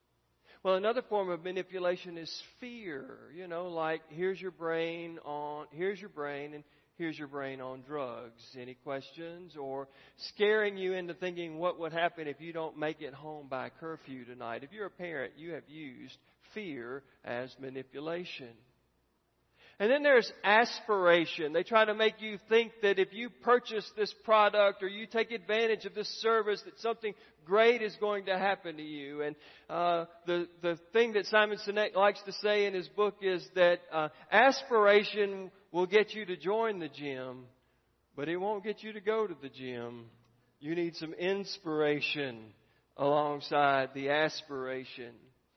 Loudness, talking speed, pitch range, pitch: -32 LUFS, 165 wpm, 145-205 Hz, 170 Hz